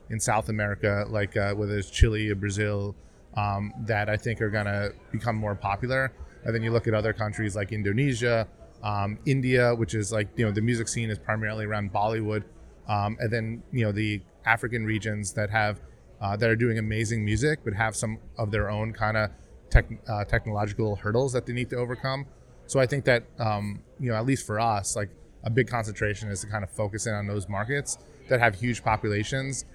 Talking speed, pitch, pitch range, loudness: 210 wpm, 110 Hz, 105-115 Hz, -28 LUFS